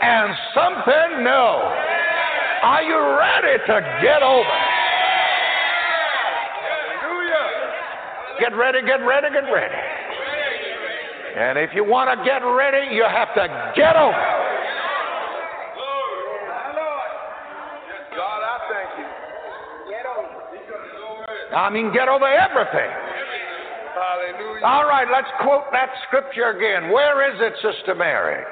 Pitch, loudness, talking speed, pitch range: 270 Hz, -19 LUFS, 95 wpm, 245-300 Hz